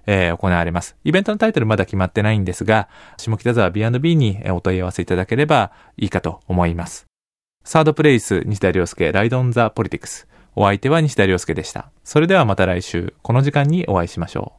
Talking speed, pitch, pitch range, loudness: 445 characters per minute, 105 Hz, 90-125 Hz, -18 LUFS